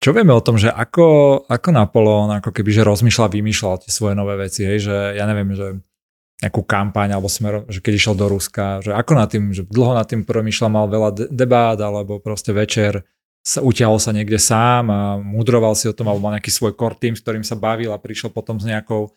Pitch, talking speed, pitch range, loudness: 110 Hz, 225 wpm, 105-115 Hz, -17 LUFS